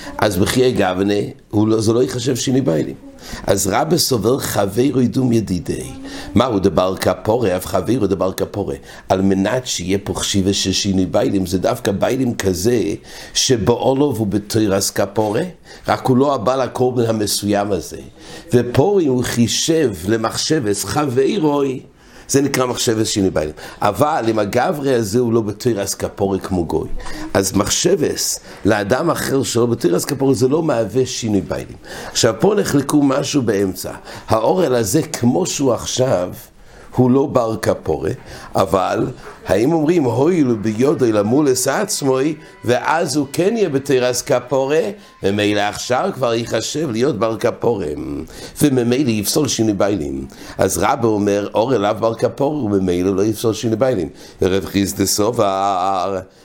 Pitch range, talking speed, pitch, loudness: 100-130 Hz, 140 wpm, 115 Hz, -17 LUFS